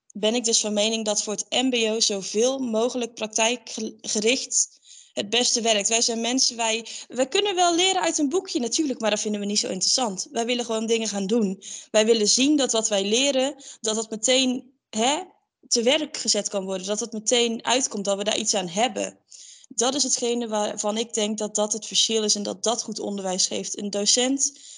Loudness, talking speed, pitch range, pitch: -23 LUFS, 205 wpm, 210-255 Hz, 230 Hz